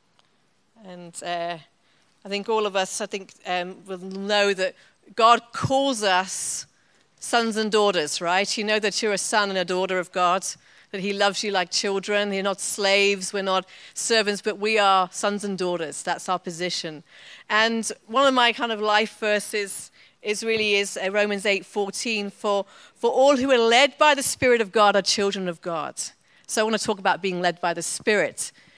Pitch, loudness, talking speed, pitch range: 200 Hz, -23 LUFS, 190 wpm, 185-215 Hz